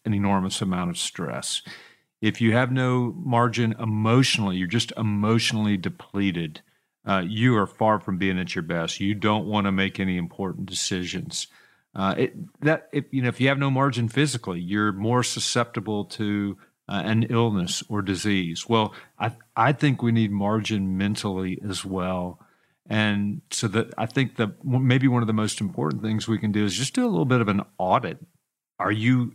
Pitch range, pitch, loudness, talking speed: 100-120 Hz, 110 Hz, -24 LUFS, 185 wpm